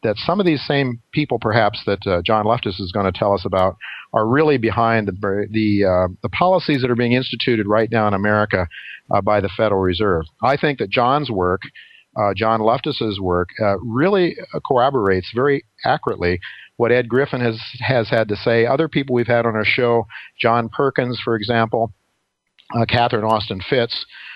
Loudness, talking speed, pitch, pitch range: -18 LUFS, 185 wpm, 115 Hz, 100-125 Hz